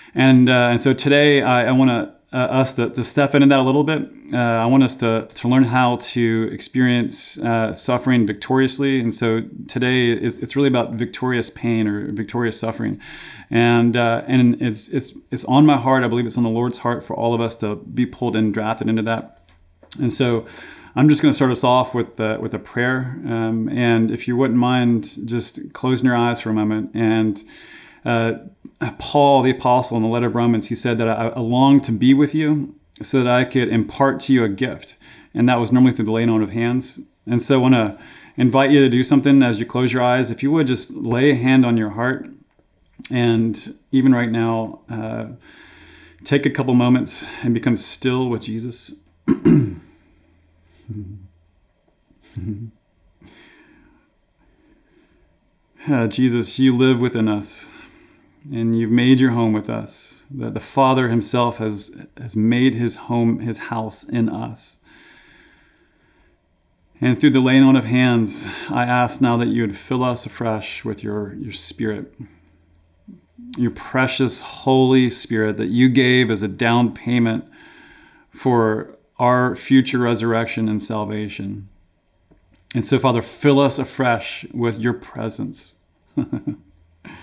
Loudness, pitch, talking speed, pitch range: -18 LUFS, 120 Hz, 170 wpm, 110-130 Hz